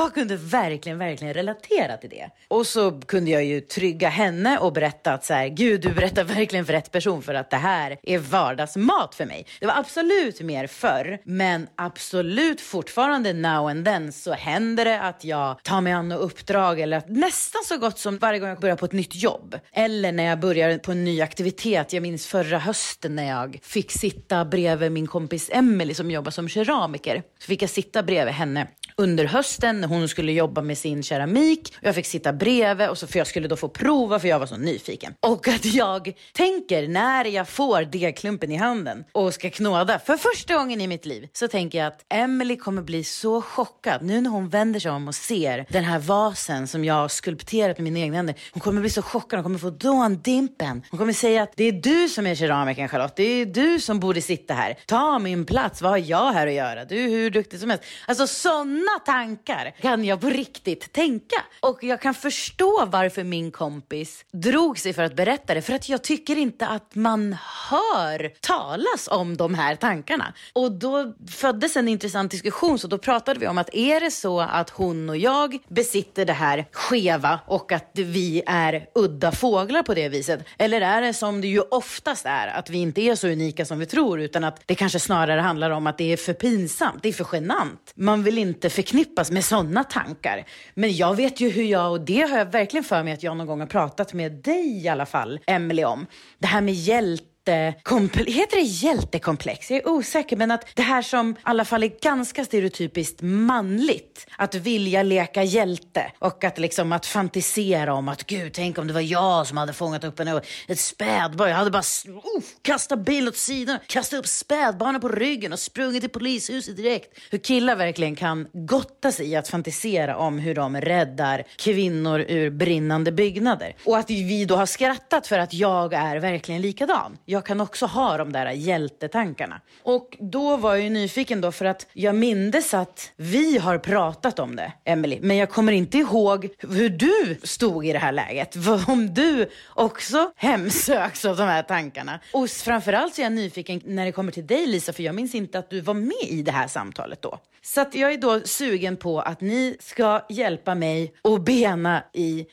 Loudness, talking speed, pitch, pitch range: -23 LUFS, 210 wpm, 195 Hz, 165-235 Hz